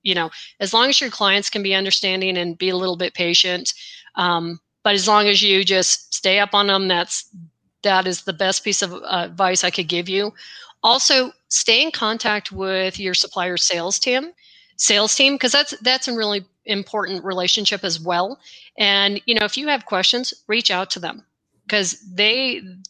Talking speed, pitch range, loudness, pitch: 190 wpm, 185-220 Hz, -18 LUFS, 195 Hz